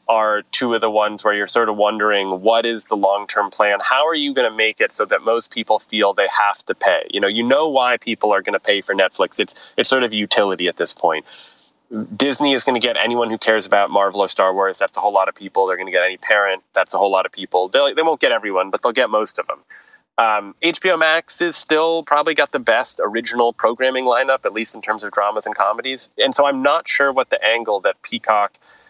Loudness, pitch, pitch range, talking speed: -17 LUFS, 115 Hz, 105-140 Hz, 255 wpm